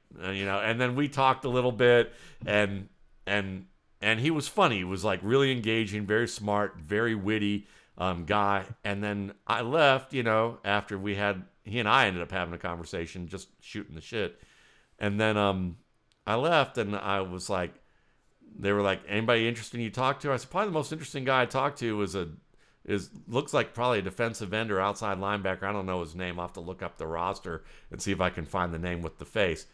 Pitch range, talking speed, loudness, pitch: 95-120 Hz, 220 wpm, -29 LUFS, 105 Hz